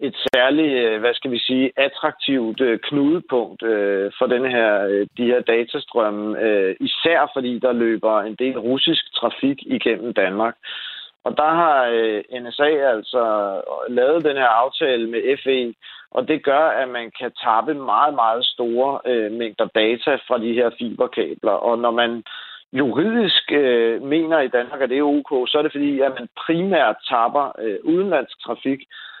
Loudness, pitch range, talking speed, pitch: -19 LUFS, 115-145 Hz, 150 wpm, 125 Hz